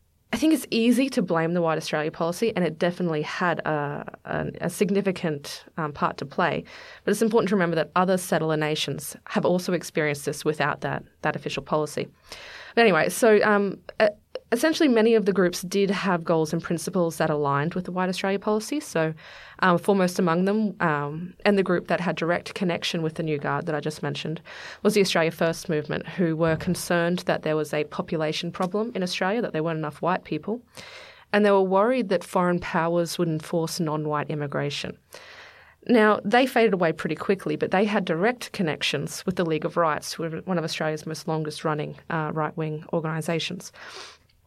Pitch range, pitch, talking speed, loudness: 155-200 Hz, 170 Hz, 195 wpm, -25 LUFS